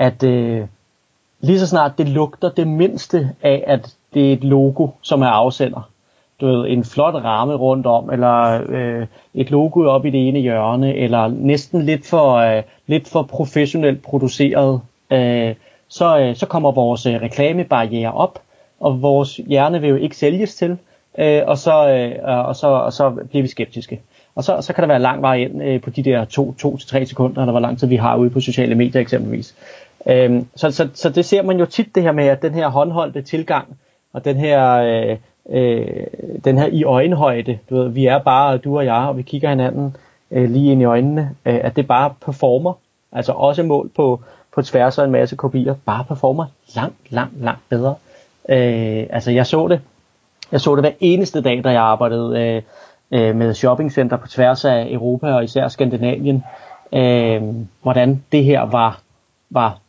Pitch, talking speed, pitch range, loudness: 130 Hz, 190 wpm, 120-145 Hz, -16 LUFS